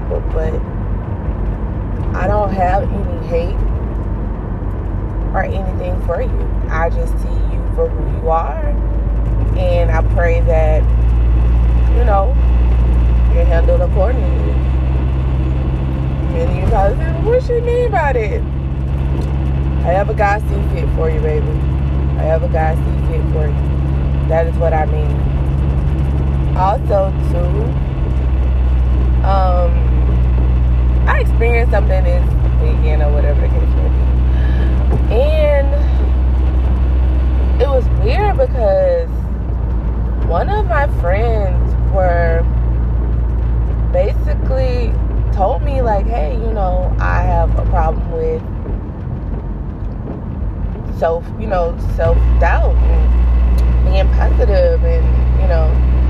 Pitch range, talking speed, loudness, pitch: 60-70 Hz, 110 wpm, -16 LUFS, 65 Hz